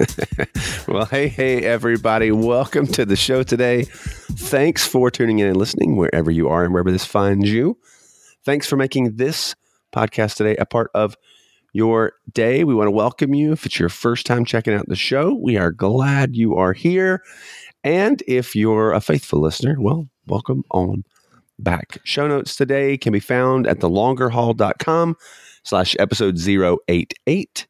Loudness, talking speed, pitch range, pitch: -18 LUFS, 165 wpm, 100-130 Hz, 115 Hz